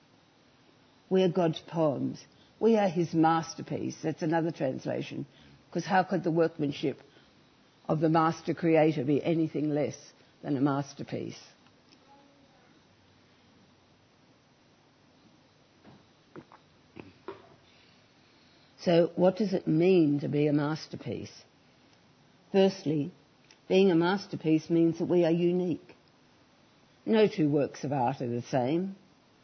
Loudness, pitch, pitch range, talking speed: -28 LUFS, 165 Hz, 150-175 Hz, 105 wpm